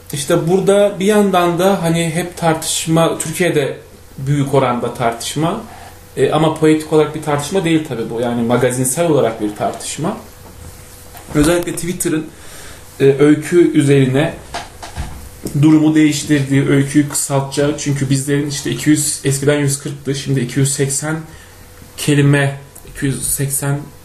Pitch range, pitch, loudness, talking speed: 130-155 Hz, 145 Hz, -15 LUFS, 110 wpm